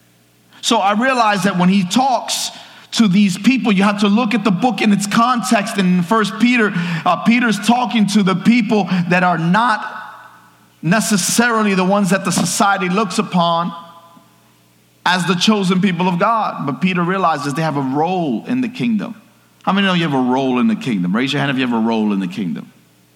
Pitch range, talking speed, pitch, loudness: 170-220 Hz, 200 wpm, 195 Hz, -16 LUFS